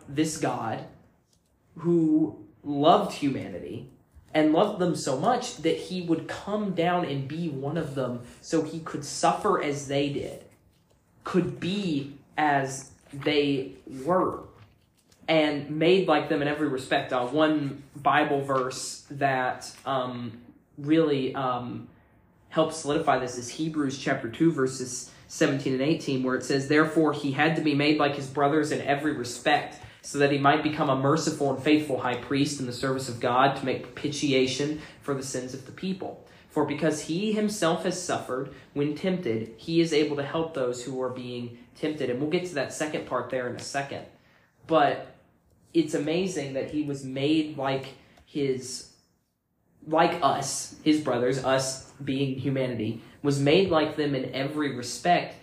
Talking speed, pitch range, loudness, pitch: 160 wpm, 130-155 Hz, -27 LUFS, 145 Hz